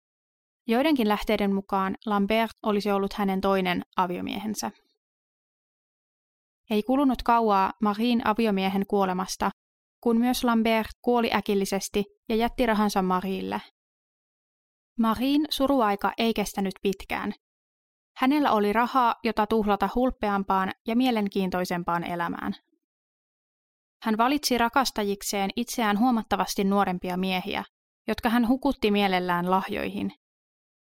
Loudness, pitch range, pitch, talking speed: -26 LUFS, 195-235 Hz, 215 Hz, 95 wpm